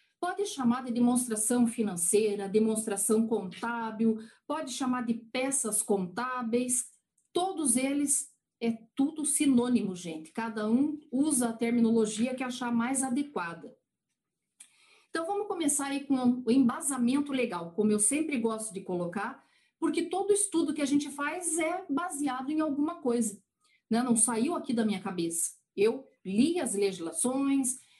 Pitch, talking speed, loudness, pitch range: 245 Hz, 135 wpm, -29 LUFS, 220-285 Hz